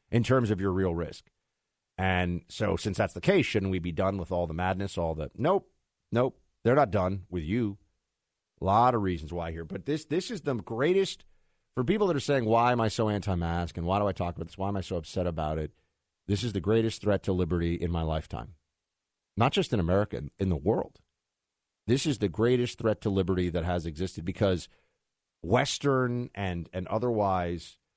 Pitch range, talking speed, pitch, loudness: 85-110 Hz, 210 wpm, 95 Hz, -29 LUFS